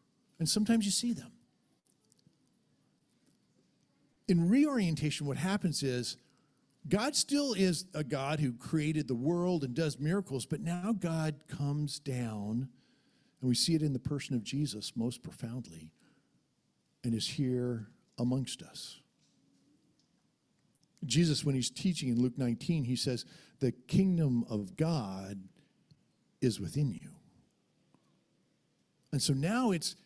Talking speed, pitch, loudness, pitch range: 125 wpm, 145 Hz, -33 LUFS, 125-170 Hz